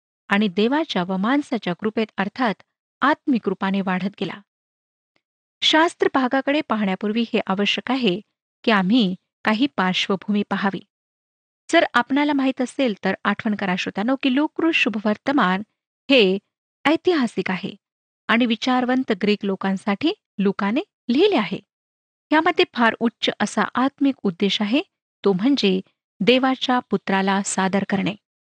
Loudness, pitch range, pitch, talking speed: -21 LUFS, 195-265 Hz, 220 Hz, 115 wpm